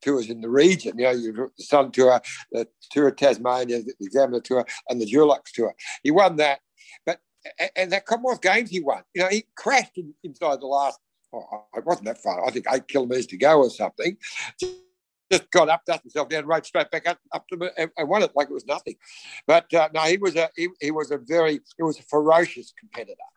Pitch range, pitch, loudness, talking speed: 135-180 Hz, 160 Hz, -23 LUFS, 235 wpm